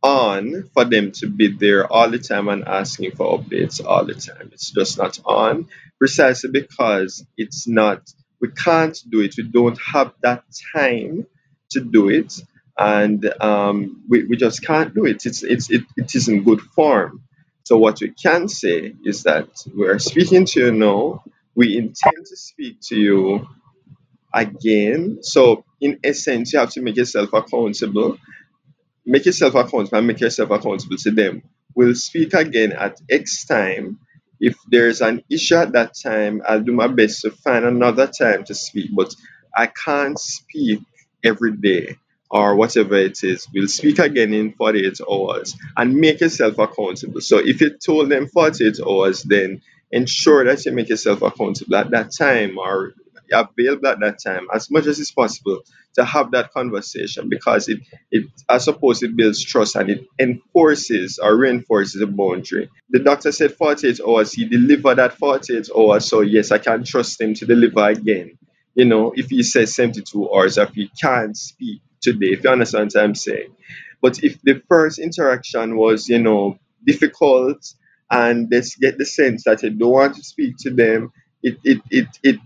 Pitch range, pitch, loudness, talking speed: 110-145 Hz, 120 Hz, -17 LUFS, 175 wpm